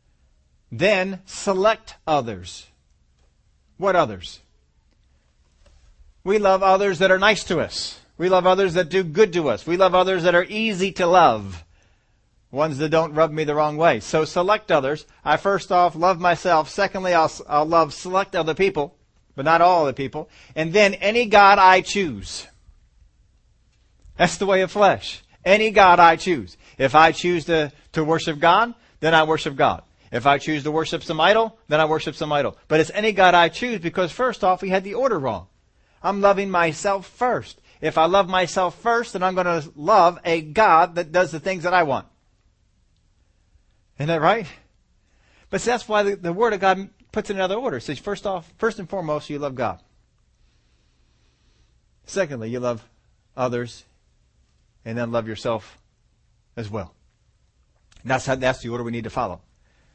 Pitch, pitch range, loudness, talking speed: 160 Hz, 115-190 Hz, -20 LUFS, 180 wpm